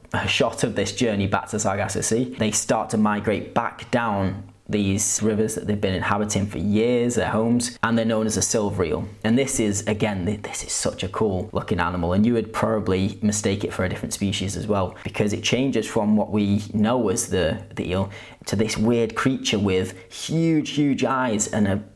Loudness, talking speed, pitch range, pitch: -23 LUFS, 205 wpm, 100-115 Hz, 105 Hz